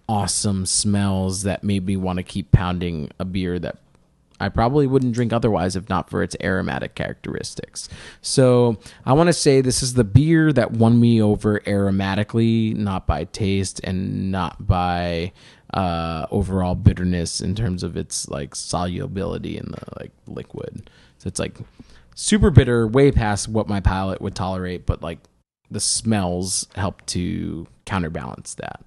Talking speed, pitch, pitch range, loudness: 160 wpm, 100 Hz, 90-115 Hz, -21 LUFS